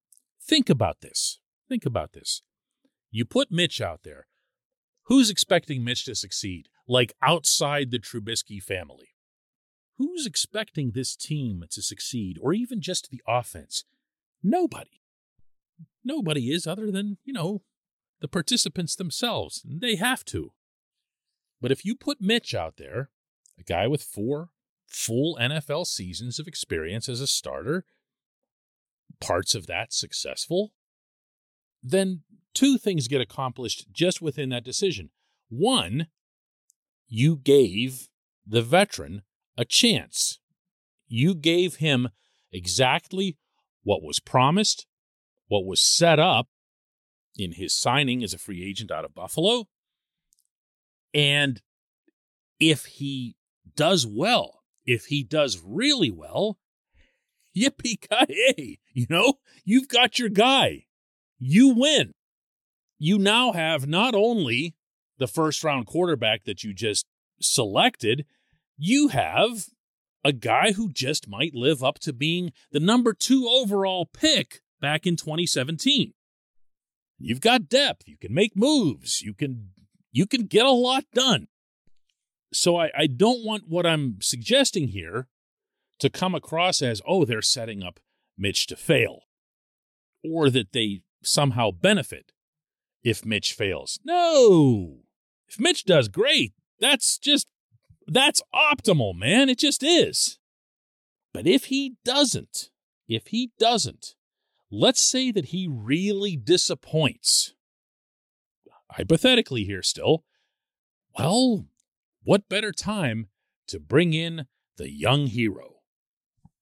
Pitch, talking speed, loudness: 160 Hz, 120 wpm, -23 LUFS